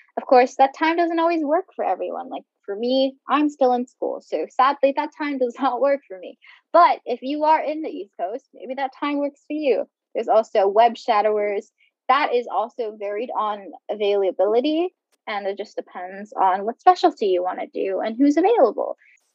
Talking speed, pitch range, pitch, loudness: 195 wpm, 210-300 Hz, 260 Hz, -21 LUFS